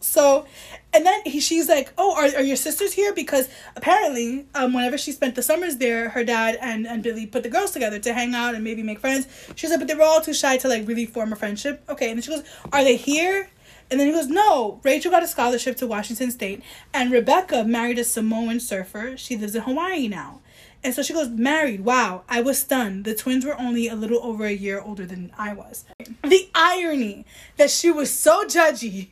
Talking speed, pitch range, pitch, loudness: 230 wpm, 230-300 Hz, 255 Hz, -21 LUFS